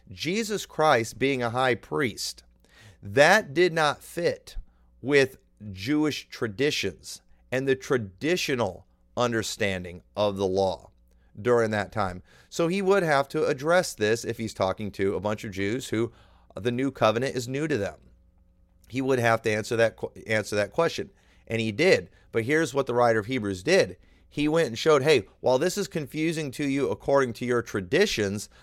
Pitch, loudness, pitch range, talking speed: 115 Hz, -26 LUFS, 95-140 Hz, 170 wpm